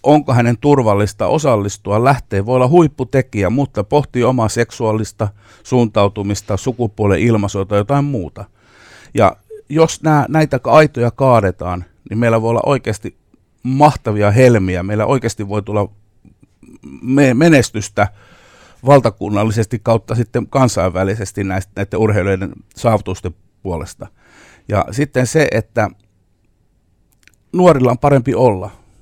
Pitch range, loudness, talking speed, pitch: 100-130 Hz, -15 LUFS, 110 wpm, 115 Hz